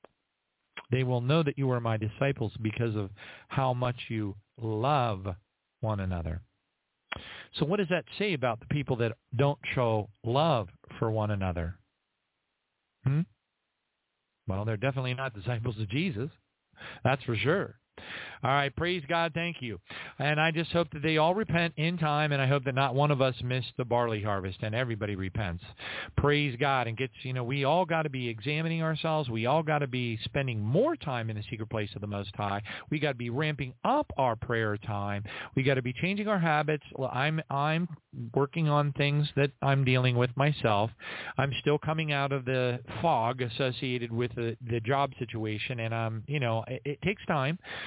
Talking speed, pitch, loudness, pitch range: 190 wpm, 130 Hz, -30 LUFS, 115-150 Hz